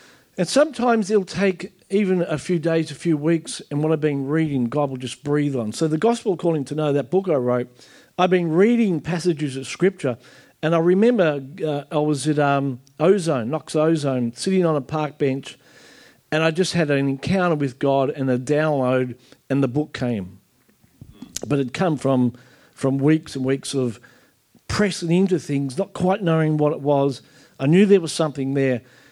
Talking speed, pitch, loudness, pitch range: 190 wpm, 150 Hz, -21 LUFS, 135-175 Hz